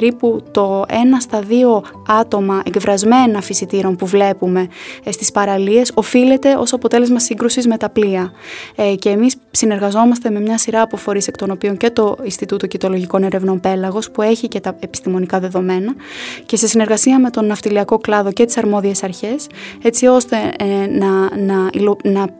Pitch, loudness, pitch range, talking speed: 210 Hz, -14 LUFS, 195-235 Hz, 165 wpm